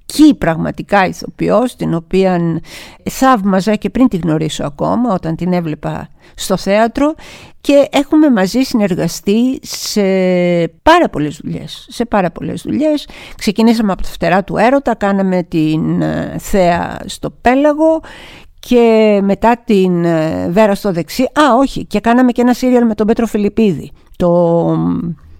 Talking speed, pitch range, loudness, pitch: 130 wpm, 175-245 Hz, -13 LUFS, 205 Hz